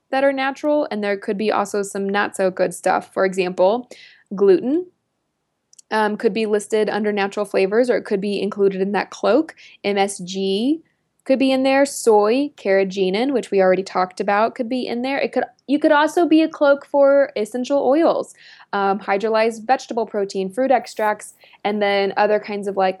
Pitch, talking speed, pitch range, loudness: 210 Hz, 185 wpm, 195-265 Hz, -19 LUFS